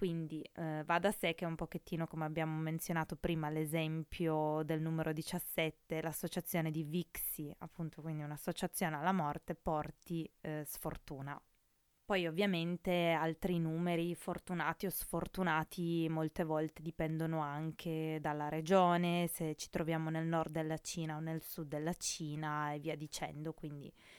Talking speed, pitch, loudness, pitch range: 140 wpm, 160 Hz, -39 LUFS, 155-175 Hz